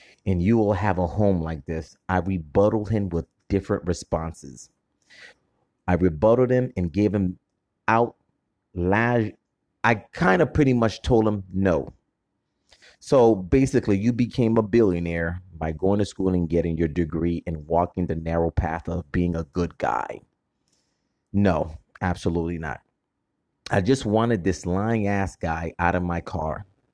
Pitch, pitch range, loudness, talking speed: 95 Hz, 85-105 Hz, -24 LUFS, 150 wpm